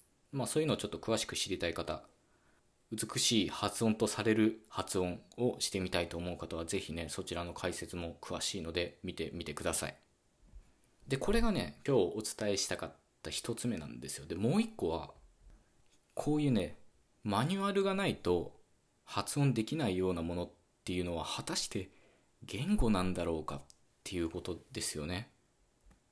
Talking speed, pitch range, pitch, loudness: 340 characters per minute, 85-115 Hz, 95 Hz, -36 LUFS